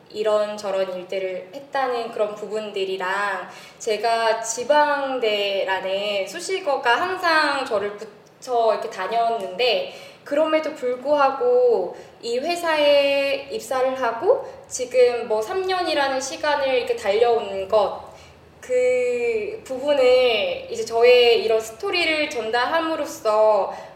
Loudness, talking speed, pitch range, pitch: -21 LUFS, 240 characters per minute, 215-335 Hz, 260 Hz